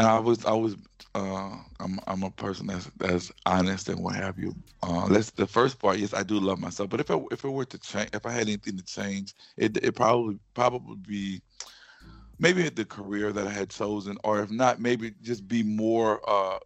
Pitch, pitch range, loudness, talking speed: 105 Hz, 95-115 Hz, -28 LUFS, 220 wpm